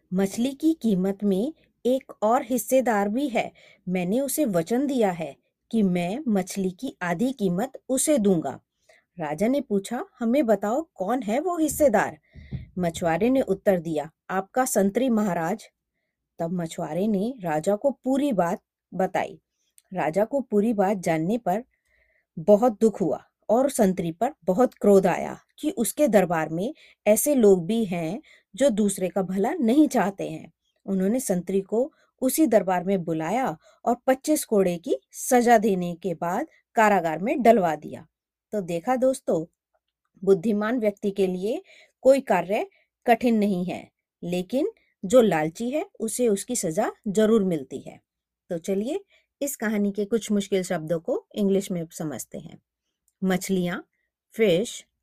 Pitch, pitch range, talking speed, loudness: 210 Hz, 185-255 Hz, 145 wpm, -24 LUFS